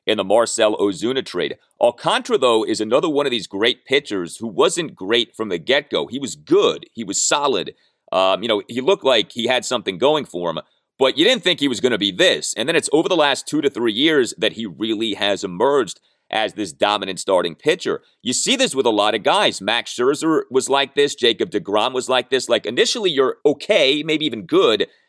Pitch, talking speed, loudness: 335 Hz, 225 wpm, -18 LUFS